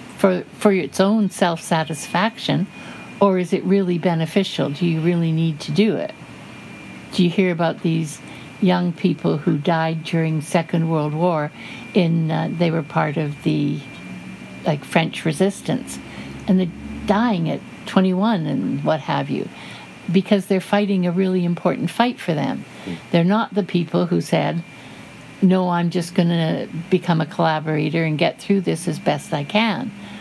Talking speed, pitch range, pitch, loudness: 160 wpm, 160-195 Hz, 175 Hz, -20 LUFS